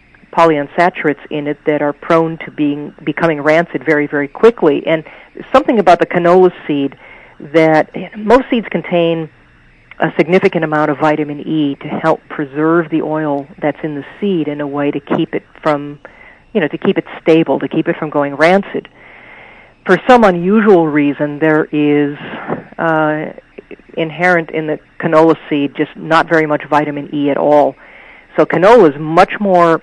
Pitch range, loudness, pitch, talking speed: 150-170 Hz, -13 LUFS, 155 Hz, 165 wpm